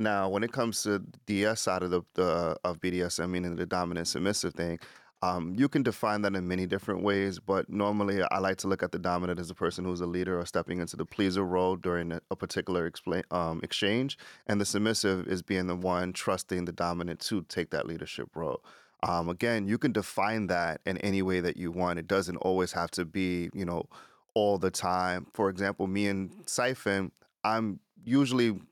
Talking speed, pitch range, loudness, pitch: 210 wpm, 90-100 Hz, -31 LUFS, 95 Hz